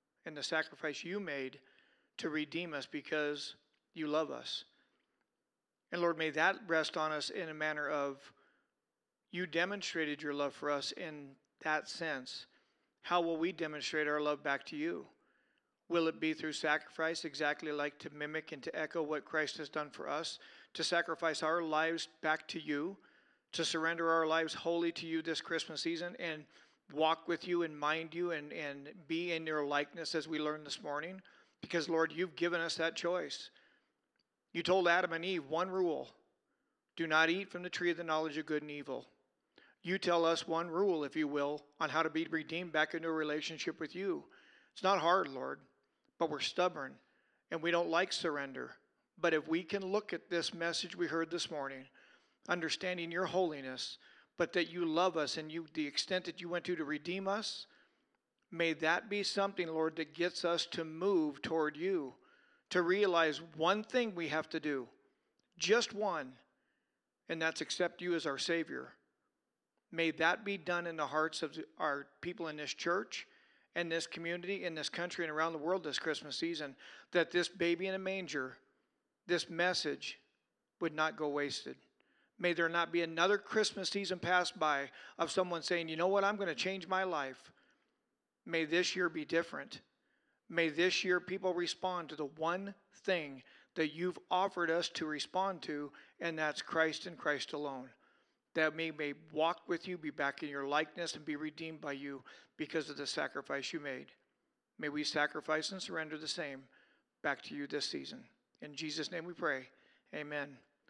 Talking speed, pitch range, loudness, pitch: 185 wpm, 155-175 Hz, -37 LUFS, 165 Hz